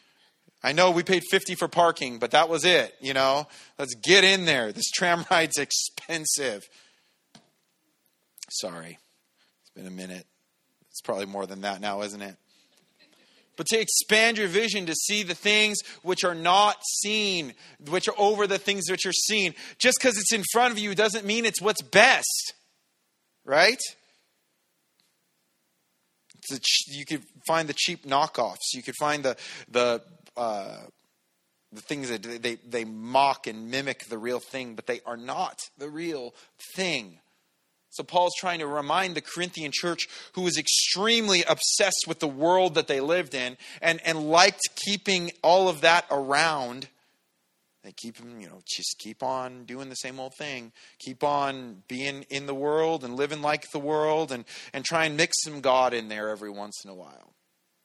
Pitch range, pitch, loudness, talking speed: 130-185 Hz, 155 Hz, -24 LUFS, 170 wpm